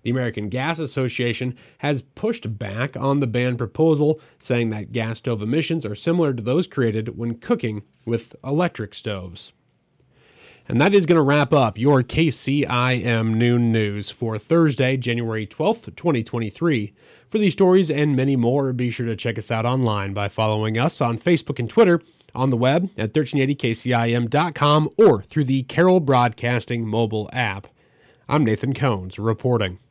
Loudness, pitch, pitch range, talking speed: -21 LUFS, 125 Hz, 115-150 Hz, 155 wpm